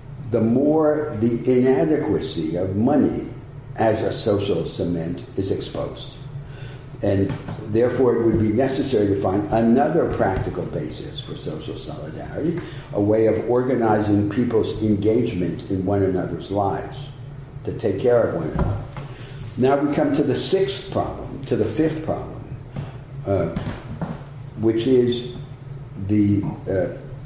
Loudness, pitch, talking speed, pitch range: -22 LUFS, 125 Hz, 130 wpm, 110-135 Hz